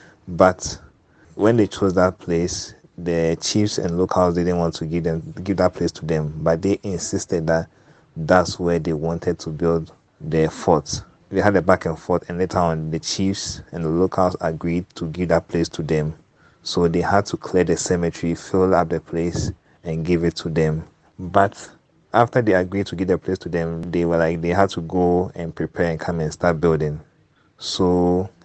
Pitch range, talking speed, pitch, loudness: 80-90 Hz, 200 wpm, 85 Hz, -21 LUFS